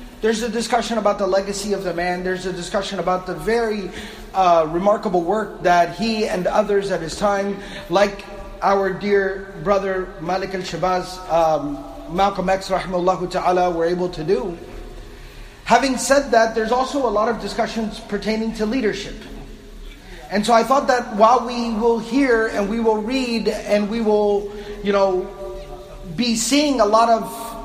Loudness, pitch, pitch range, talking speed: -20 LUFS, 200 Hz, 185-225 Hz, 165 wpm